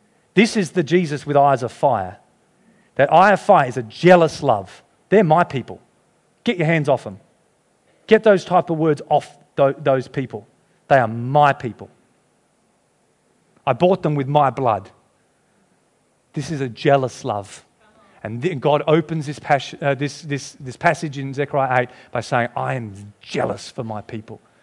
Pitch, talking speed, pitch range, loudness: 140 Hz, 165 wpm, 125-160 Hz, -19 LUFS